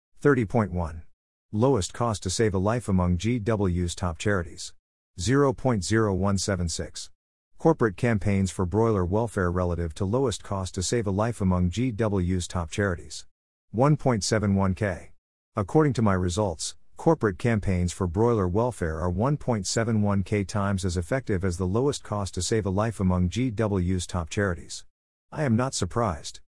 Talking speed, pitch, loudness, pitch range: 135 wpm, 100 Hz, -26 LUFS, 90-115 Hz